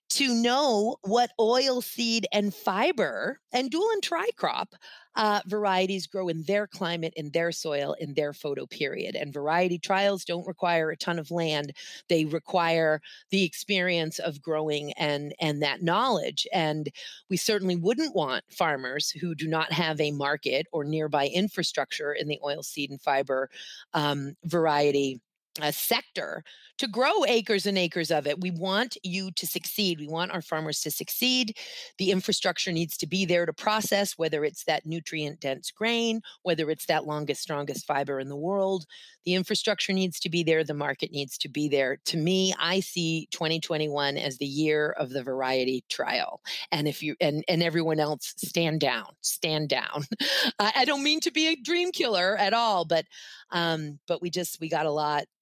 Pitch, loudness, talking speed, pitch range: 170 Hz, -27 LUFS, 180 wpm, 150-195 Hz